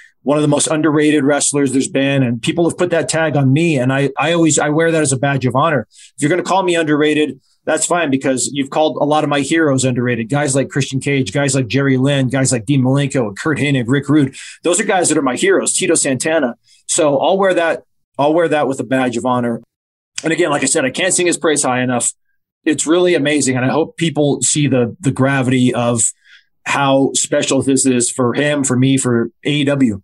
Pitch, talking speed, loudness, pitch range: 140 Hz, 235 wpm, -15 LUFS, 130-155 Hz